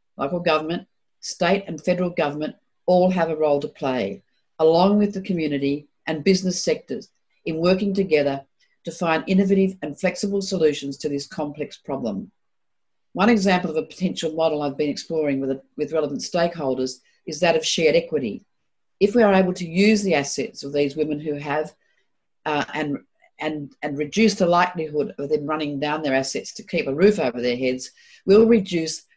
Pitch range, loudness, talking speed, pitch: 145-185 Hz, -22 LUFS, 175 wpm, 160 Hz